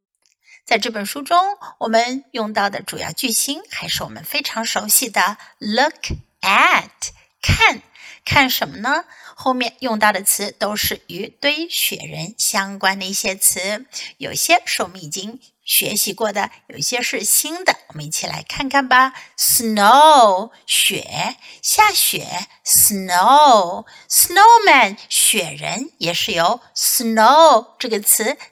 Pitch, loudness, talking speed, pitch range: 230 Hz, -16 LUFS, 225 characters per minute, 200-280 Hz